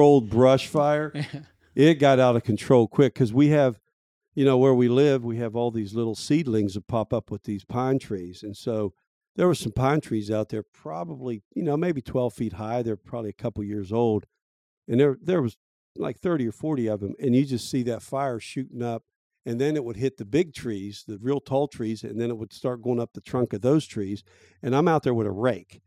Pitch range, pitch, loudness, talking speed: 110-135 Hz, 120 Hz, -25 LUFS, 235 wpm